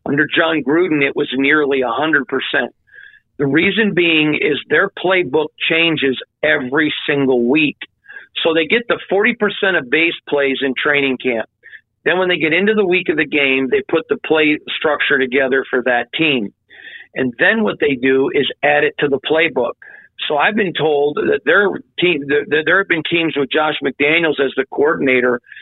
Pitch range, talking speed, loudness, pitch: 140-185 Hz, 175 wpm, -15 LUFS, 155 Hz